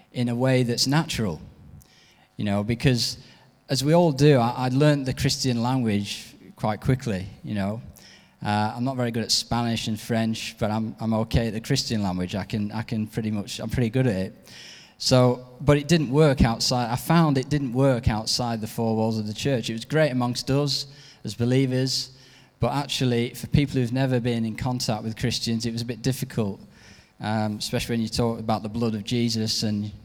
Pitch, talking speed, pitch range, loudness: 120 Hz, 205 wpm, 110-130 Hz, -24 LUFS